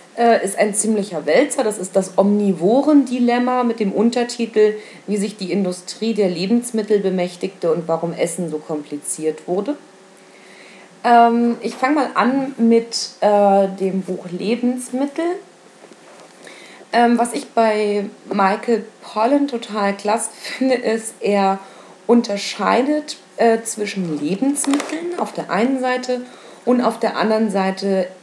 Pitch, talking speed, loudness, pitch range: 220 Hz, 125 wpm, -18 LUFS, 195-240 Hz